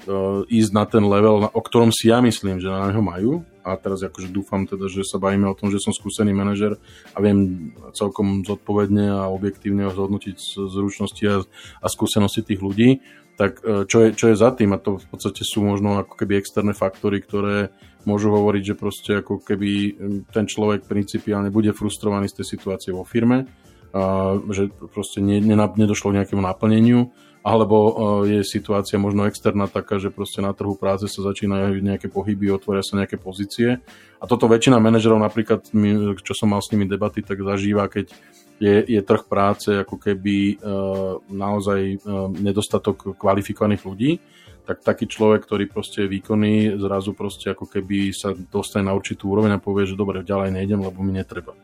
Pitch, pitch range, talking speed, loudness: 100 Hz, 100-105 Hz, 175 wpm, -21 LUFS